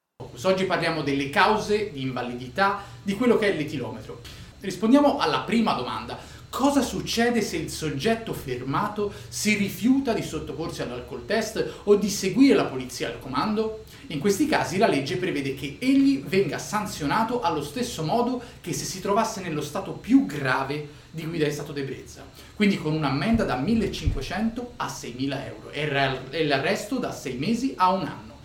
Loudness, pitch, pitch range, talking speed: -25 LUFS, 185 Hz, 145-220 Hz, 160 wpm